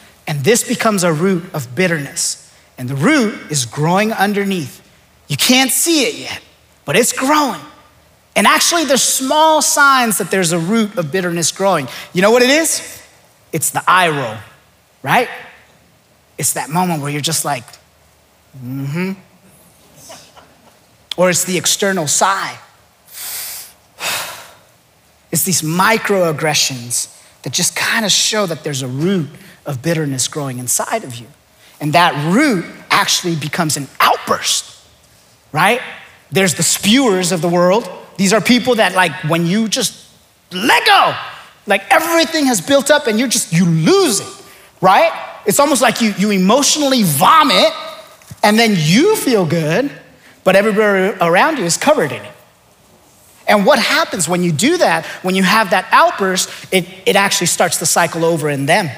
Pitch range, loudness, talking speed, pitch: 160-230 Hz, -14 LUFS, 155 wpm, 185 Hz